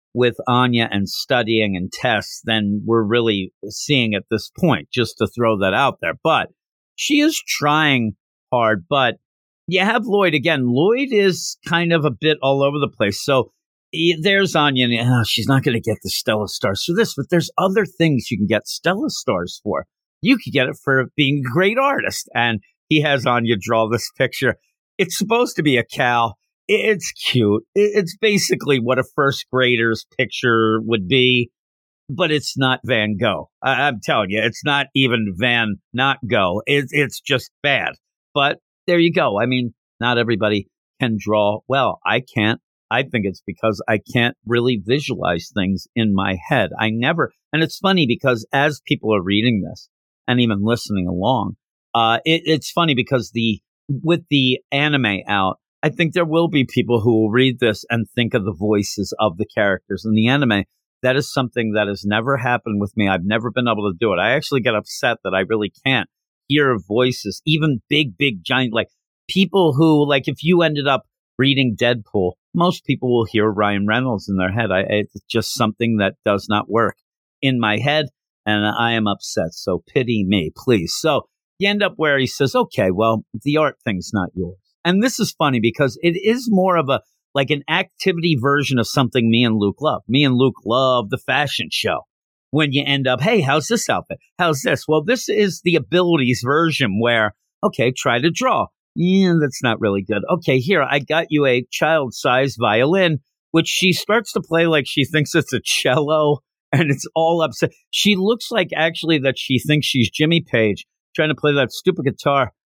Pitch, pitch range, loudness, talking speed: 130 Hz, 115-155 Hz, -18 LUFS, 190 wpm